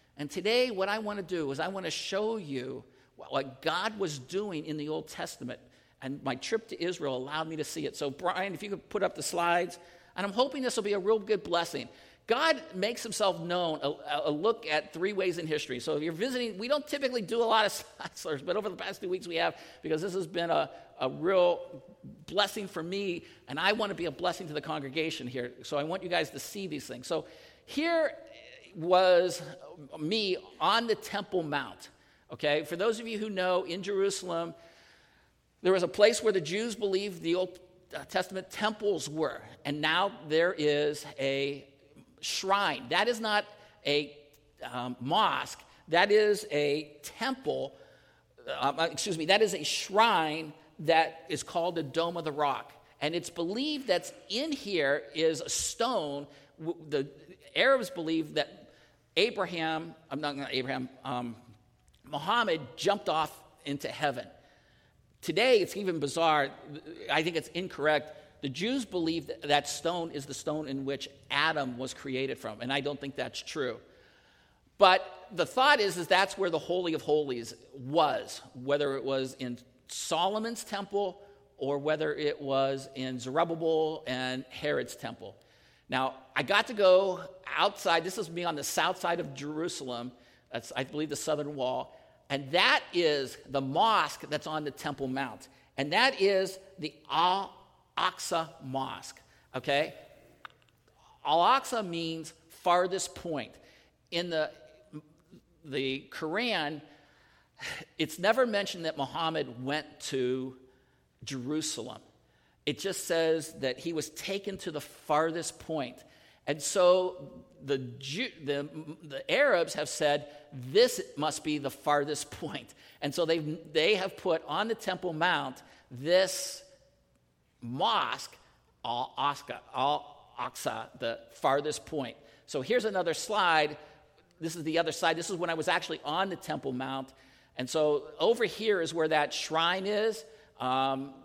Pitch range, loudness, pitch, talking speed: 145-190 Hz, -31 LUFS, 160 Hz, 160 wpm